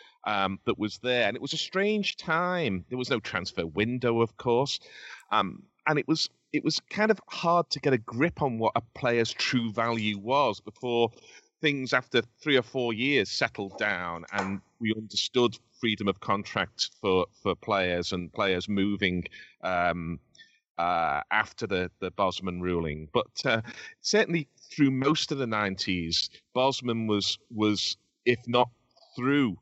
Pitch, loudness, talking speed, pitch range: 115 Hz, -28 LUFS, 160 wpm, 100-135 Hz